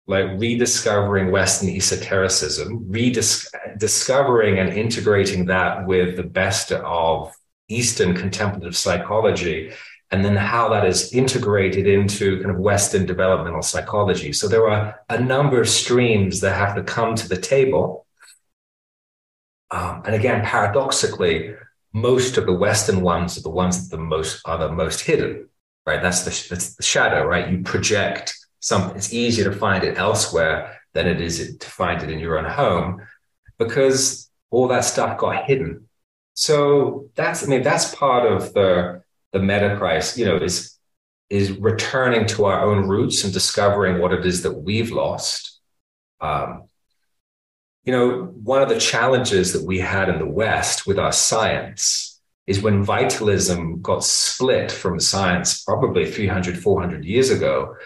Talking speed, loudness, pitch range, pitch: 155 wpm, -19 LUFS, 90-115 Hz, 100 Hz